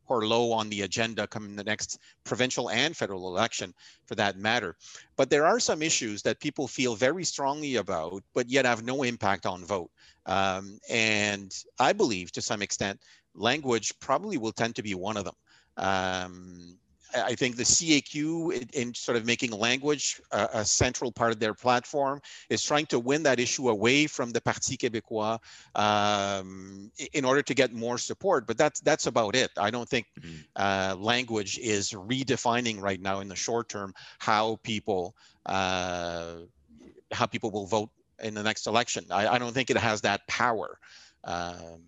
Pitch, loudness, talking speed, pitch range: 110 Hz, -28 LUFS, 175 wpm, 100-125 Hz